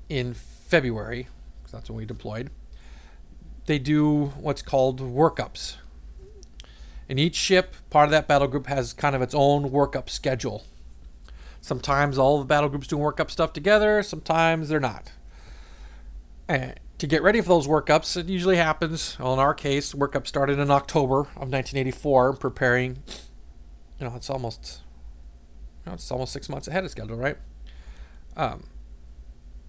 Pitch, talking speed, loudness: 130 Hz, 150 wpm, -24 LUFS